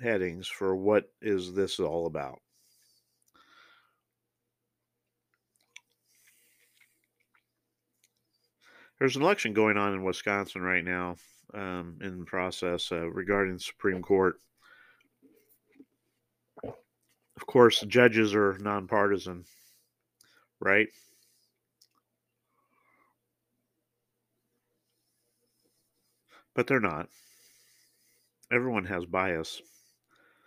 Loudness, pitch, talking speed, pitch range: -28 LUFS, 100 Hz, 75 wpm, 90-110 Hz